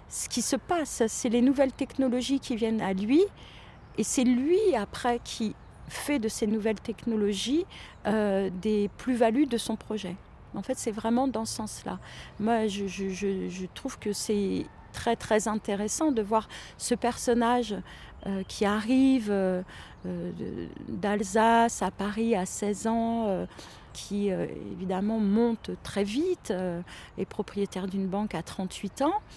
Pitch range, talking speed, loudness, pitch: 200-245 Hz, 150 wpm, -29 LUFS, 220 Hz